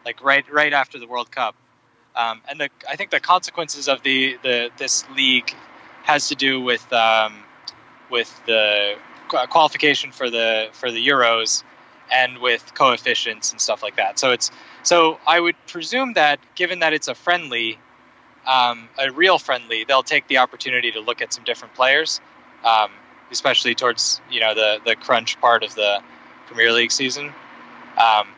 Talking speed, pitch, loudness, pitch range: 170 wpm, 130 Hz, -19 LUFS, 115-150 Hz